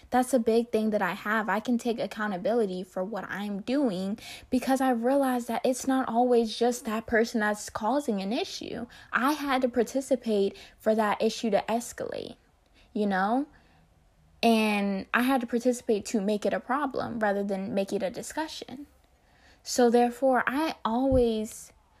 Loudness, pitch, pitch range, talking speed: -28 LUFS, 230 Hz, 210-255 Hz, 165 wpm